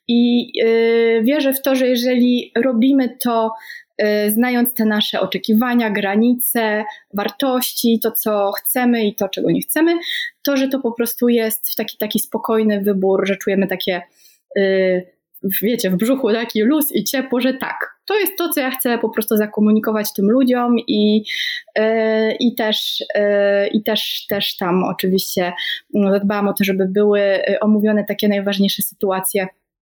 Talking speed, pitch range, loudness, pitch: 145 wpm, 200-245 Hz, -17 LUFS, 220 Hz